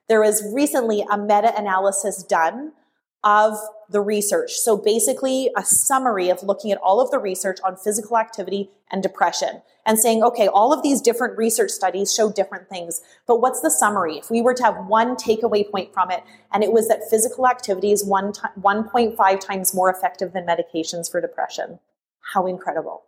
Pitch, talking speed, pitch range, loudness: 210 Hz, 180 wpm, 195-235 Hz, -20 LUFS